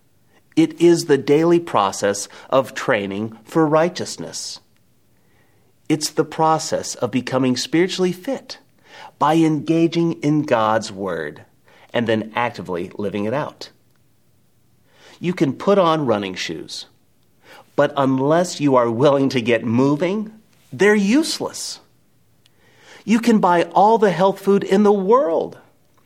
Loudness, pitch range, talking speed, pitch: -19 LUFS, 125-180 Hz, 120 wpm, 155 Hz